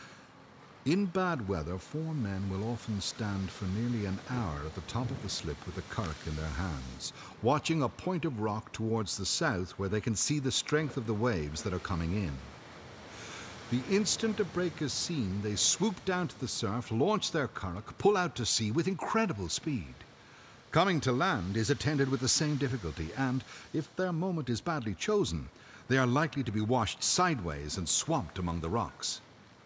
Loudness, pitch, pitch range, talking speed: -32 LUFS, 115 Hz, 95-150 Hz, 190 wpm